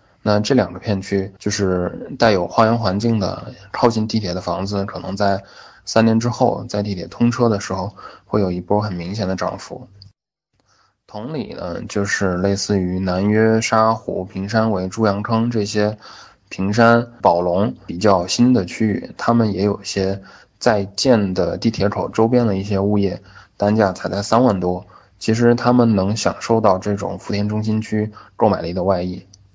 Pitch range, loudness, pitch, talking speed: 95-110 Hz, -19 LUFS, 105 Hz, 250 characters per minute